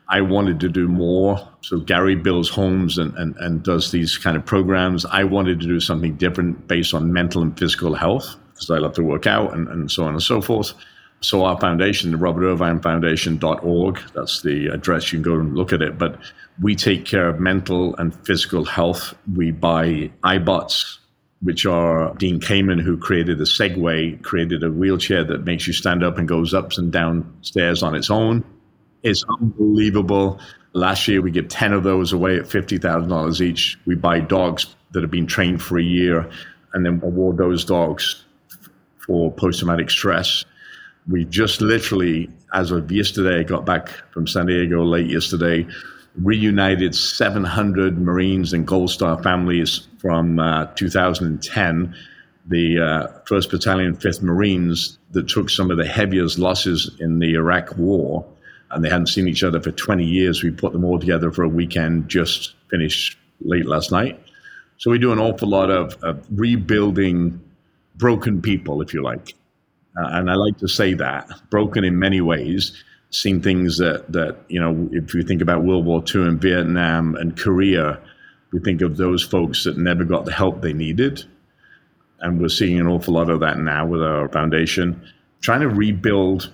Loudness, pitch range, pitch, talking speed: -19 LUFS, 85-95 Hz, 90 Hz, 180 wpm